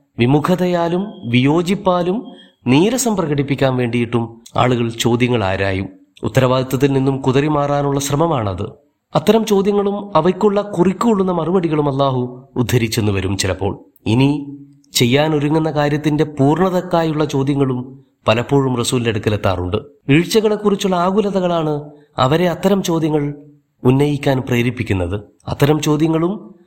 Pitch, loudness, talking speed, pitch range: 145 Hz, -17 LUFS, 90 wpm, 125-170 Hz